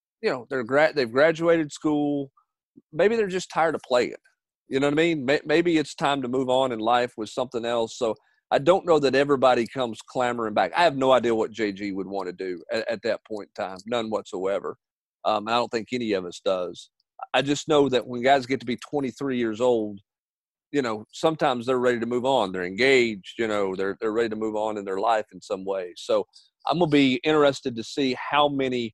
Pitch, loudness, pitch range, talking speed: 125 Hz, -24 LUFS, 110-145 Hz, 225 wpm